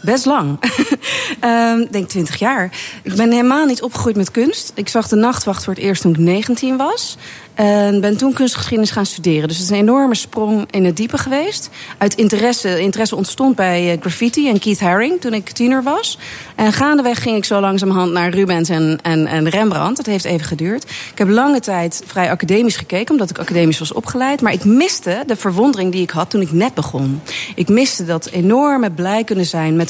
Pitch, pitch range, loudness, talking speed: 205 Hz, 180-245 Hz, -15 LUFS, 205 wpm